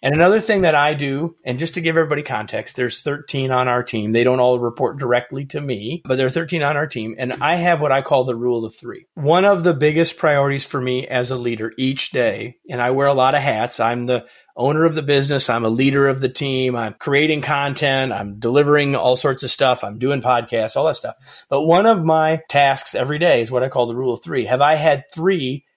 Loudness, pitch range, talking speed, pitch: -18 LUFS, 125-155 Hz, 245 wpm, 135 Hz